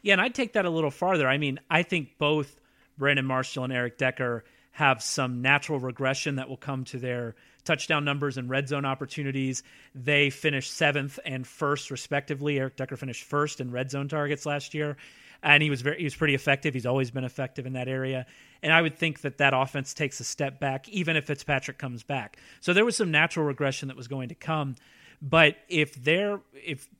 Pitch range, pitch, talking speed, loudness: 130-150 Hz, 140 Hz, 210 wpm, -27 LUFS